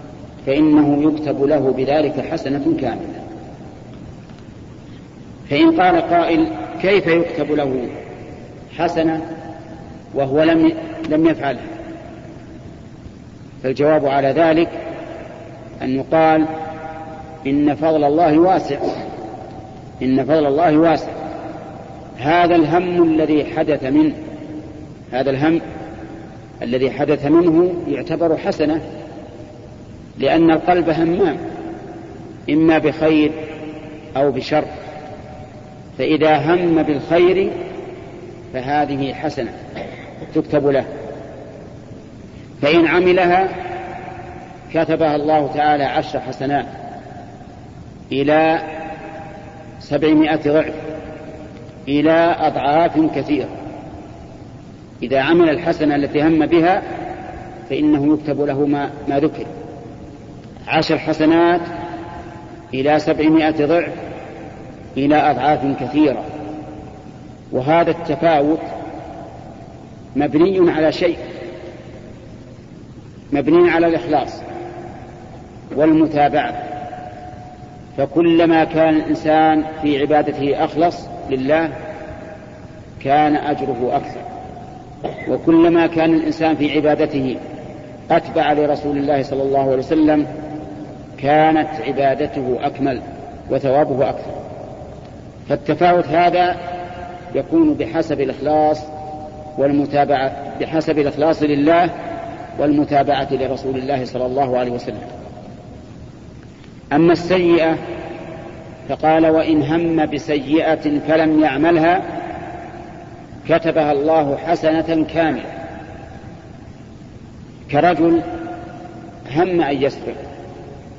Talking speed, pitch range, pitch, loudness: 75 wpm, 145-165 Hz, 155 Hz, -17 LUFS